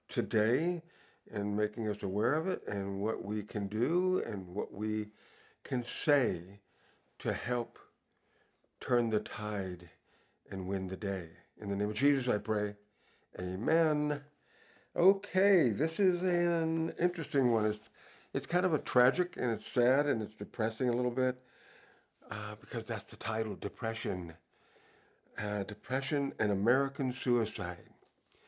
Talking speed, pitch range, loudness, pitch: 140 wpm, 105-135 Hz, -33 LUFS, 110 Hz